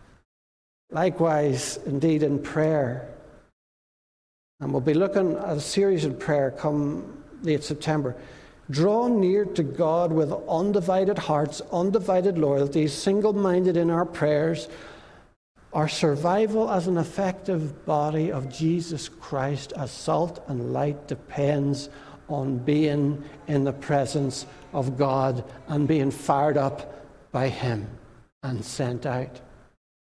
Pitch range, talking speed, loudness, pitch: 140-170 Hz, 115 wpm, -25 LUFS, 150 Hz